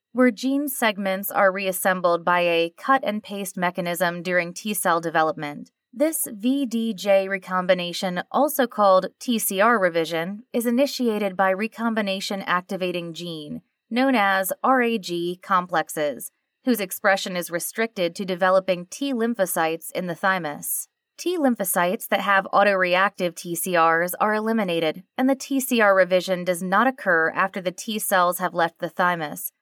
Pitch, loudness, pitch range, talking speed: 190 Hz, -22 LUFS, 175-225 Hz, 135 wpm